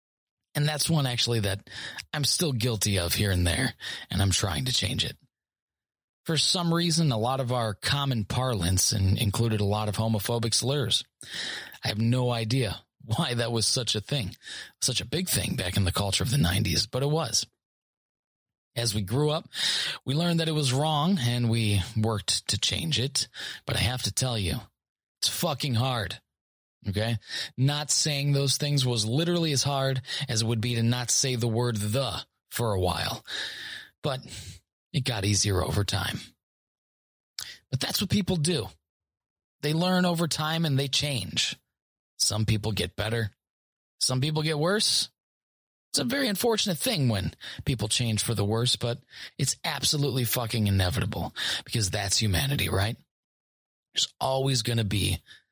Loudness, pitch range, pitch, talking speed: -27 LUFS, 105-140 Hz, 120 Hz, 170 wpm